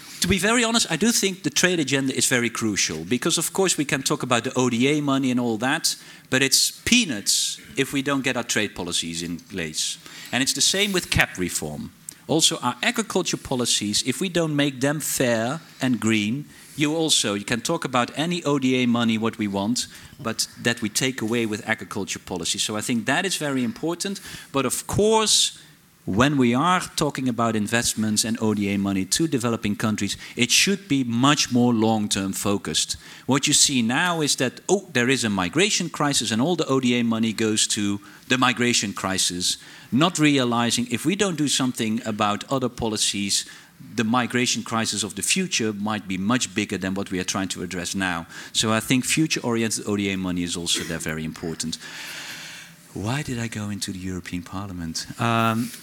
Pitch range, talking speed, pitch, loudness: 105-145 Hz, 190 wpm, 120 Hz, -22 LUFS